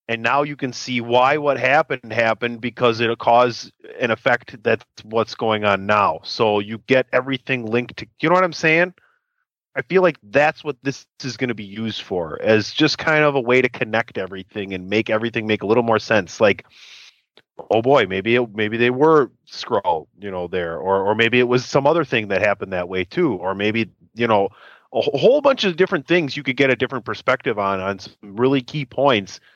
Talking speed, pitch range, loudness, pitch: 215 wpm, 110-140 Hz, -19 LUFS, 120 Hz